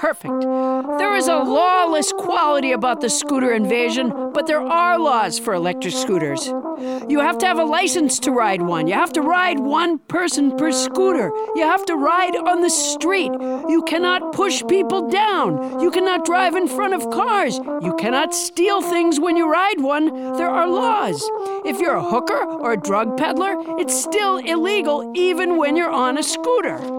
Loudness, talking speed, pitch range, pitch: -18 LUFS, 180 wpm, 260-360 Hz, 320 Hz